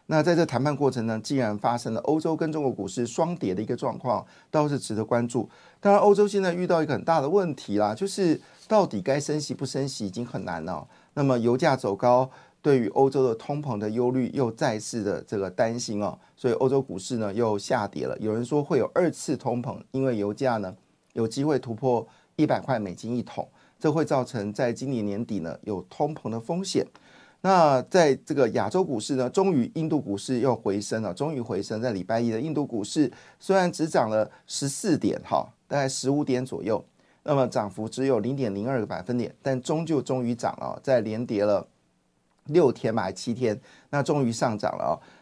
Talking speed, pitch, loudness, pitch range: 305 characters per minute, 130 Hz, -26 LUFS, 110-145 Hz